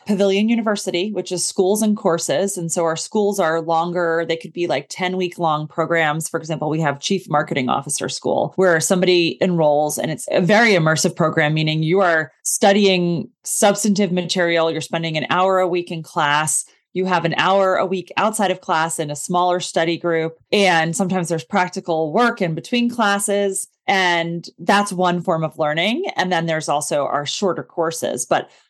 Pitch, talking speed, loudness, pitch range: 175 Hz, 185 wpm, -19 LUFS, 160-190 Hz